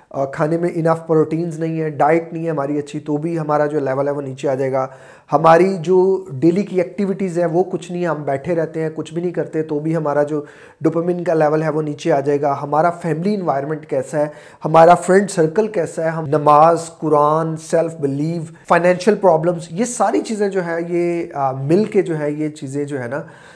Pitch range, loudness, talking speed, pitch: 150-175 Hz, -18 LUFS, 215 wpm, 160 Hz